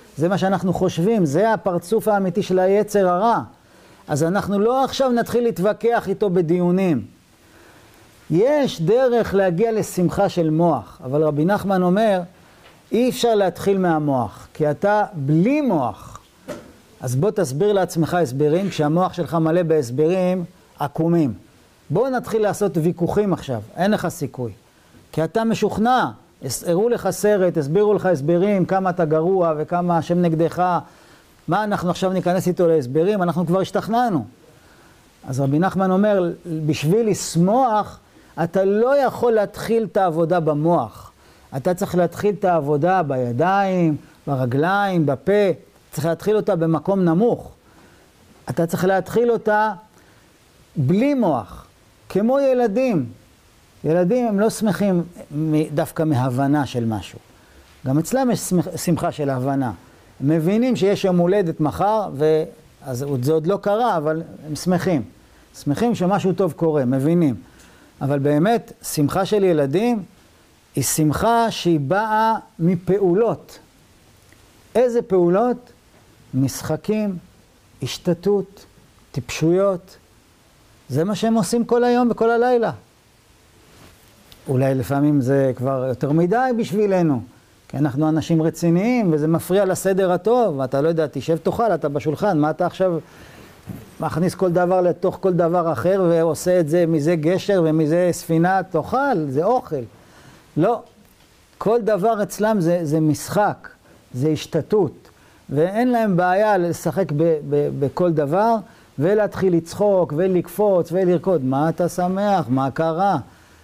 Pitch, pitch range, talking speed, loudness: 175 Hz, 150-200 Hz, 125 wpm, -20 LUFS